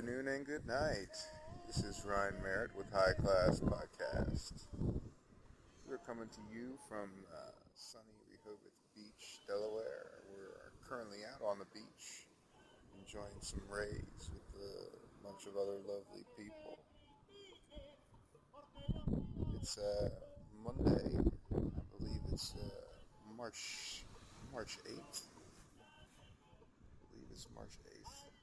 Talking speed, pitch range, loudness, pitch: 115 wpm, 100-155 Hz, -43 LUFS, 105 Hz